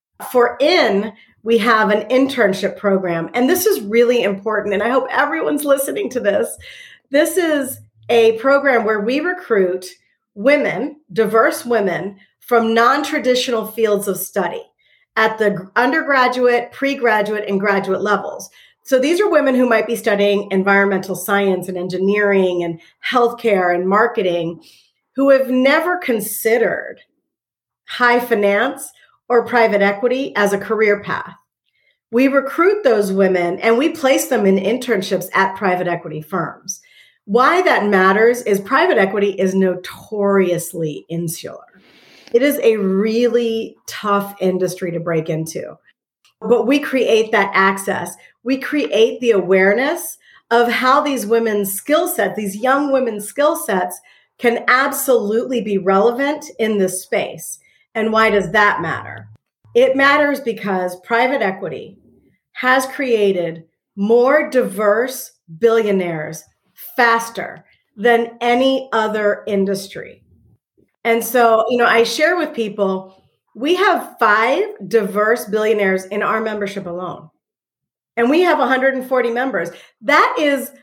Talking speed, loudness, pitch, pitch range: 130 wpm, -16 LUFS, 225 Hz, 195-255 Hz